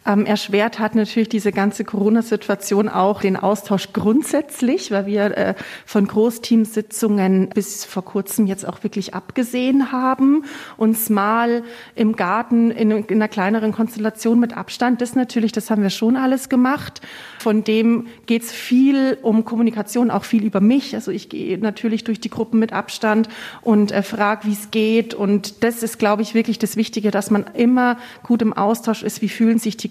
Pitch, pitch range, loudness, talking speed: 220 Hz, 205-235 Hz, -19 LUFS, 175 wpm